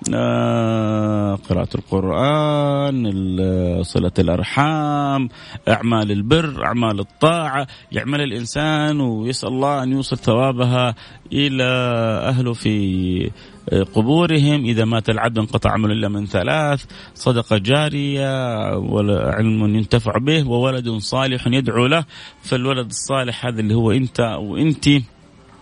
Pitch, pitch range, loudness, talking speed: 120 Hz, 105-135 Hz, -19 LUFS, 100 wpm